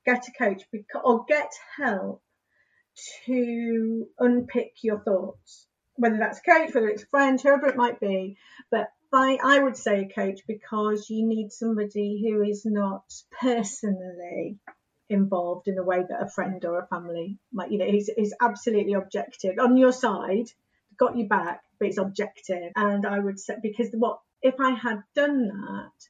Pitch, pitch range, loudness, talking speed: 220 Hz, 200-245 Hz, -25 LUFS, 170 wpm